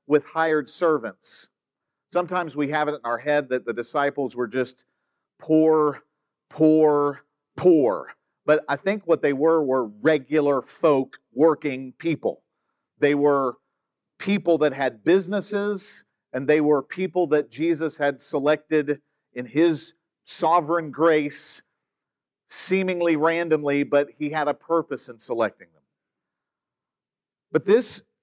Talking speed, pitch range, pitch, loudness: 125 wpm, 145-170 Hz, 150 Hz, -23 LUFS